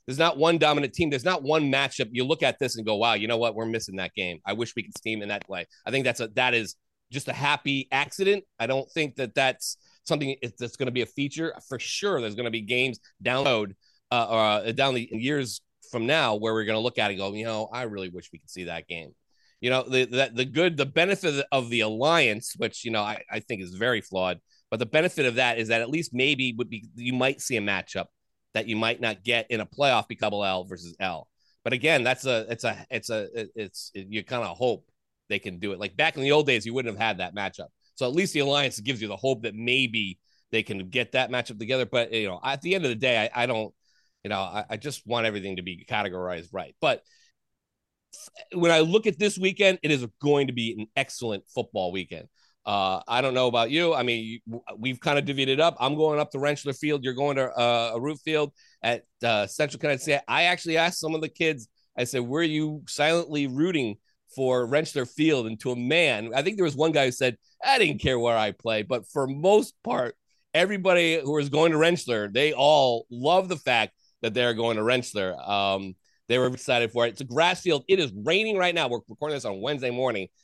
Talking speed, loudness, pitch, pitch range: 245 wpm, -26 LUFS, 125 Hz, 110-150 Hz